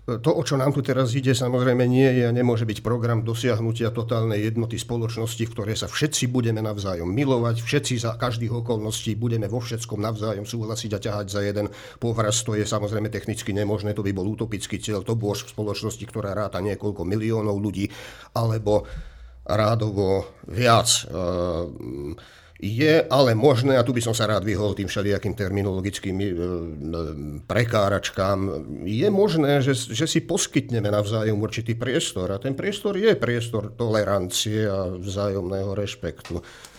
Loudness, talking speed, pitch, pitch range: -24 LUFS, 150 wpm, 110 Hz, 100-120 Hz